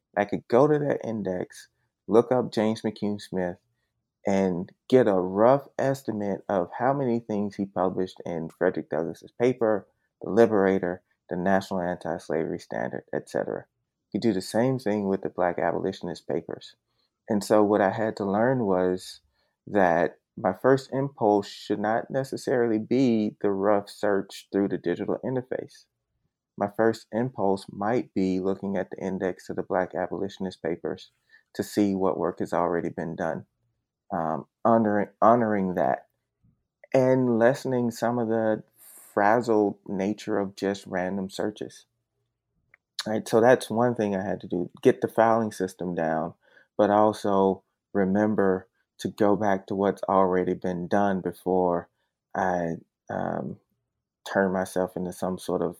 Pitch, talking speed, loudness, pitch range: 100 Hz, 150 wpm, -26 LUFS, 95-115 Hz